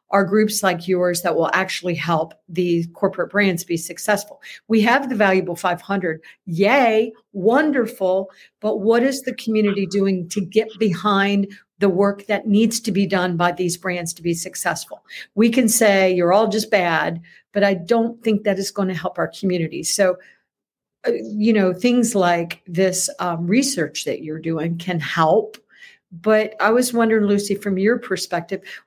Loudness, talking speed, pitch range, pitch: -19 LUFS, 165 wpm, 180-220 Hz, 200 Hz